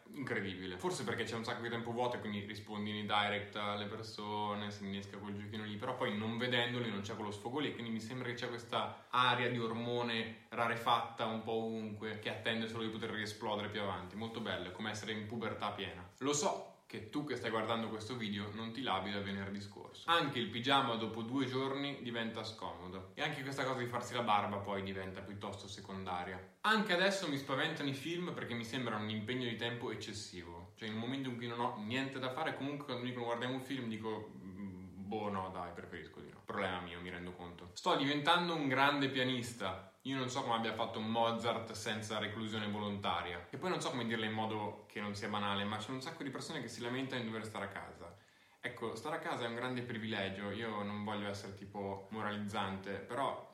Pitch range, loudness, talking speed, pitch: 105-125 Hz, -39 LUFS, 215 wpm, 110 Hz